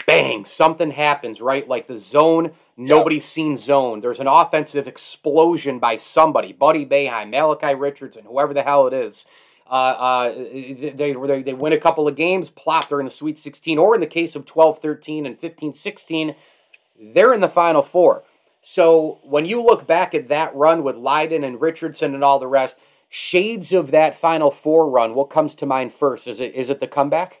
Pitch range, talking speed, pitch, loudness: 140-160 Hz, 195 wpm, 150 Hz, -18 LUFS